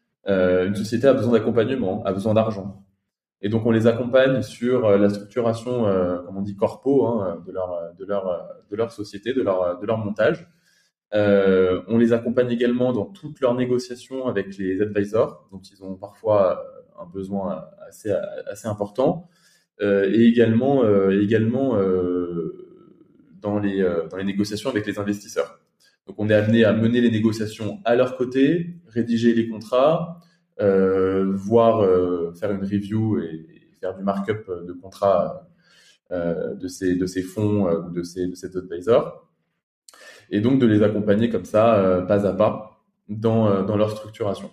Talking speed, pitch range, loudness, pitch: 165 wpm, 95-115 Hz, -21 LUFS, 105 Hz